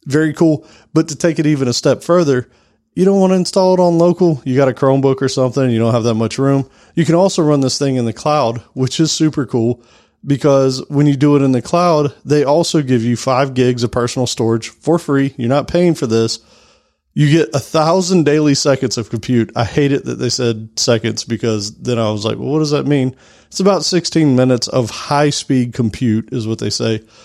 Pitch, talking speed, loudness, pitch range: 135 Hz, 230 wpm, -15 LUFS, 120-155 Hz